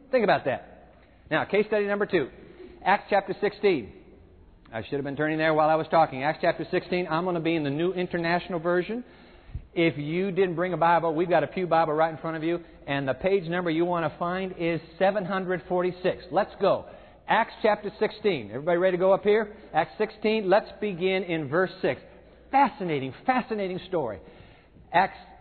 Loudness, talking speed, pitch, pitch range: -26 LUFS, 195 wpm, 180 Hz, 165-200 Hz